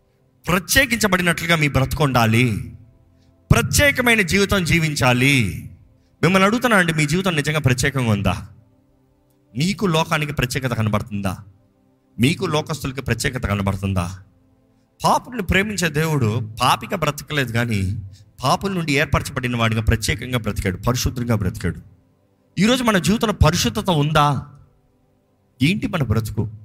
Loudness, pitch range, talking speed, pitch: -19 LUFS, 110-160 Hz, 100 wpm, 130 Hz